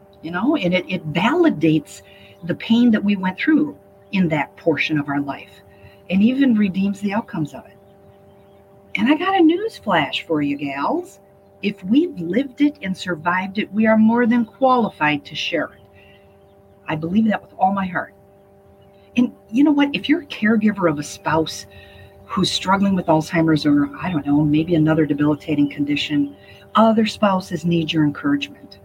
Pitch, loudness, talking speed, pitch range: 165 Hz, -19 LUFS, 175 wpm, 140-215 Hz